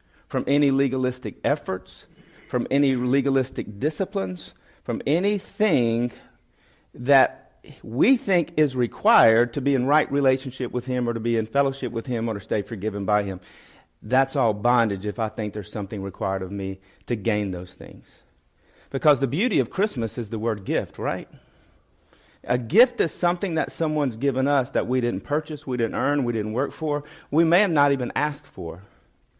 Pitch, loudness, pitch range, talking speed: 125 Hz, -24 LUFS, 110-145 Hz, 175 wpm